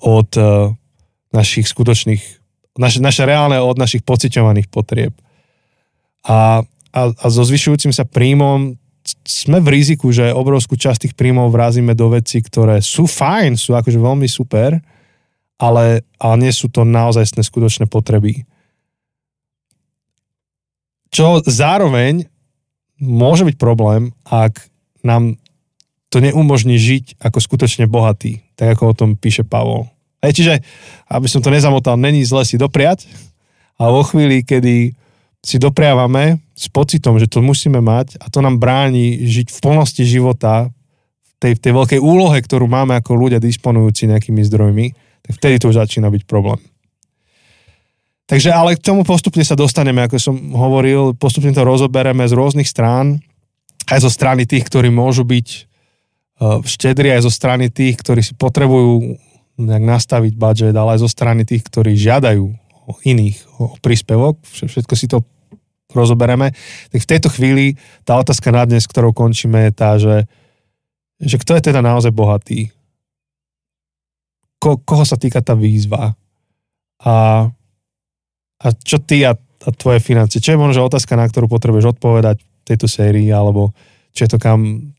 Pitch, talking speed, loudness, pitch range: 125 Hz, 150 wpm, -13 LUFS, 115-140 Hz